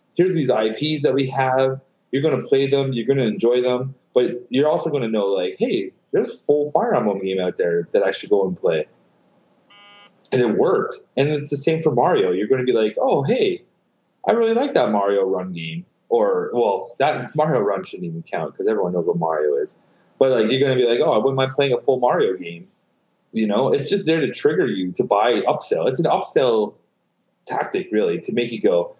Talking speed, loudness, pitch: 230 wpm, -20 LUFS, 165 Hz